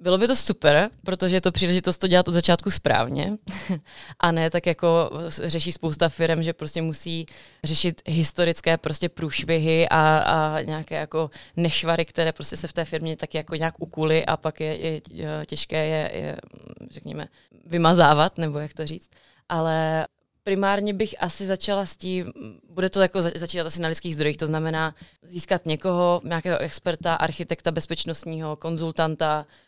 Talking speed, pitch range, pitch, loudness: 160 wpm, 155-175 Hz, 165 Hz, -23 LUFS